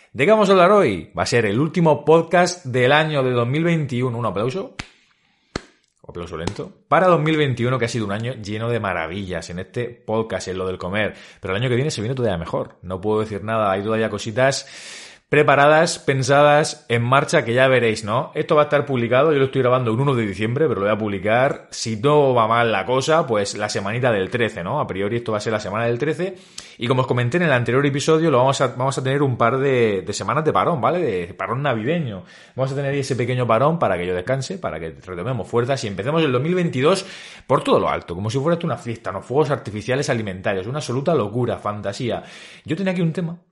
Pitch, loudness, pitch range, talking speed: 125 Hz, -20 LUFS, 110-150 Hz, 230 wpm